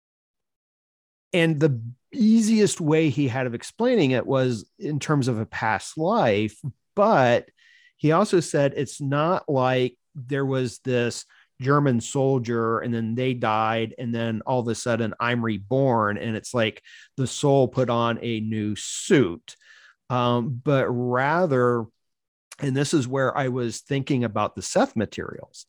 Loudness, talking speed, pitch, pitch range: -23 LUFS, 150 wpm, 125 Hz, 115-145 Hz